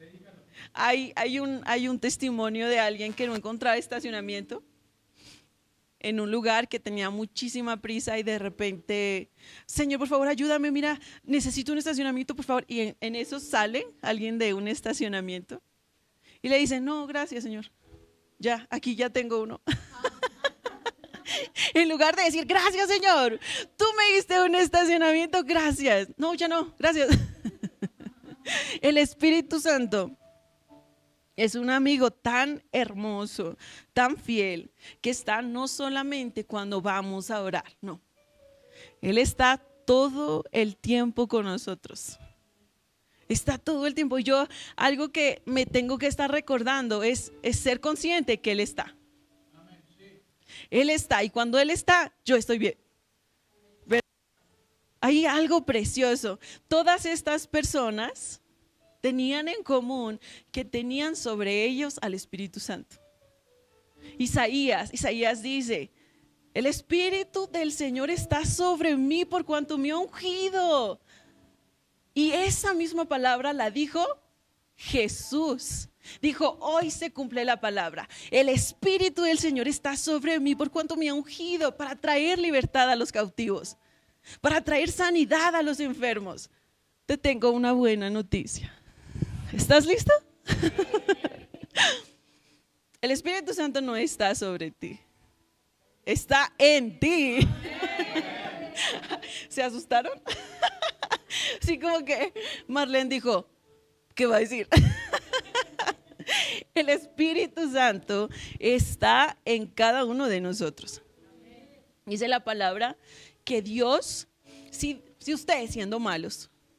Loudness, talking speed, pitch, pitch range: -27 LUFS, 120 wpm, 265 Hz, 225-310 Hz